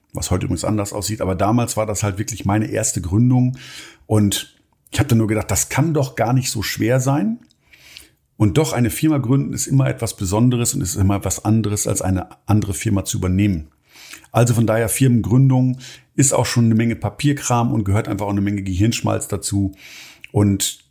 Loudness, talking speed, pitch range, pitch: -19 LUFS, 190 wpm, 100-125 Hz, 110 Hz